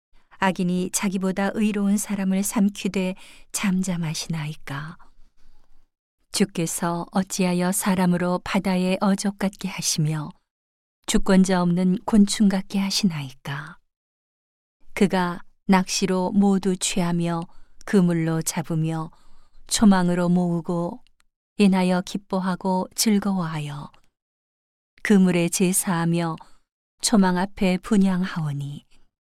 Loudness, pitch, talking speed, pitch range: -22 LUFS, 185 Hz, 225 characters per minute, 170-195 Hz